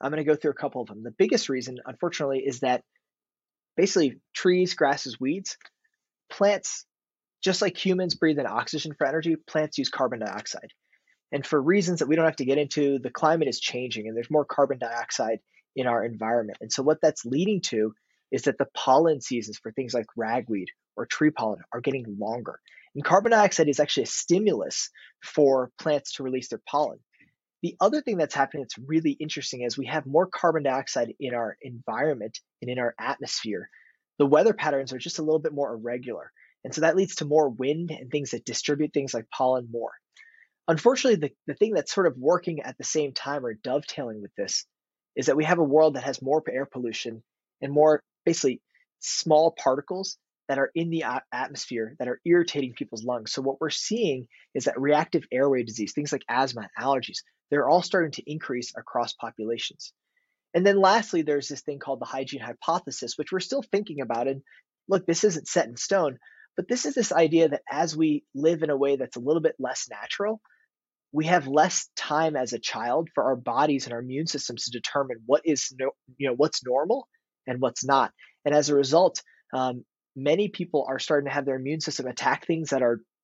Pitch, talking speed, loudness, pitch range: 145 Hz, 200 wpm, -26 LUFS, 130-165 Hz